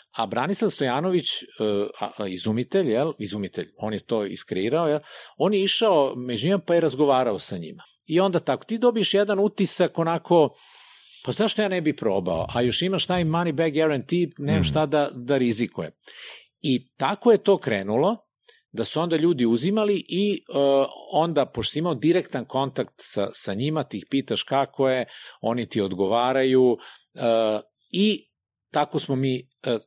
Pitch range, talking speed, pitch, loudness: 125-180 Hz, 165 wpm, 150 Hz, -24 LUFS